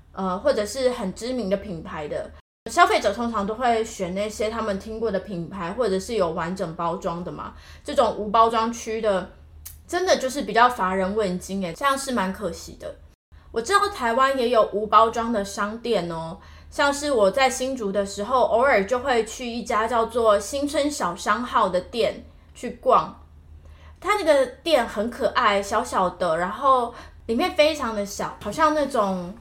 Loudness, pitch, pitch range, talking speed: -23 LUFS, 215 Hz, 190-255 Hz, 260 characters per minute